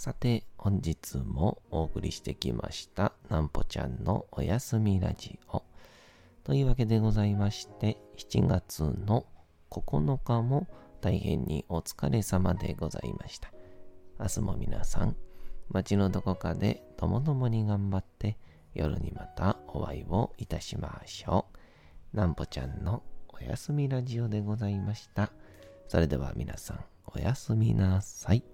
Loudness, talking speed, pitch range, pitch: -32 LUFS, 265 characters per minute, 85-110 Hz, 100 Hz